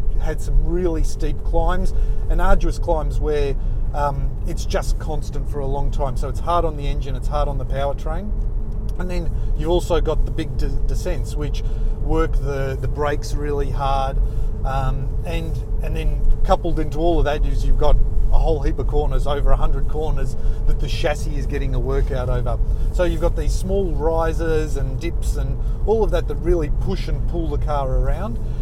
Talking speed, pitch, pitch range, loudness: 195 wpm, 135 Hz, 110-145 Hz, -23 LUFS